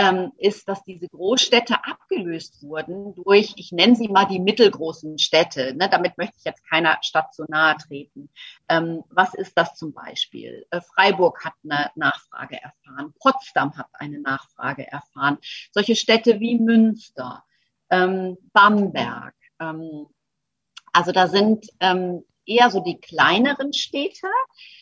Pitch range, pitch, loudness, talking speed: 160-215 Hz, 185 Hz, -20 LUFS, 125 wpm